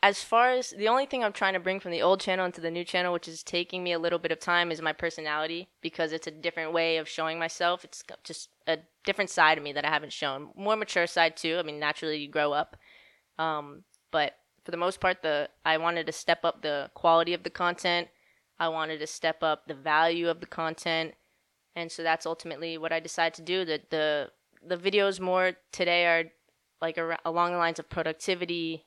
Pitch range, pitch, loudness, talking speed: 160-175 Hz, 165 Hz, -29 LUFS, 225 wpm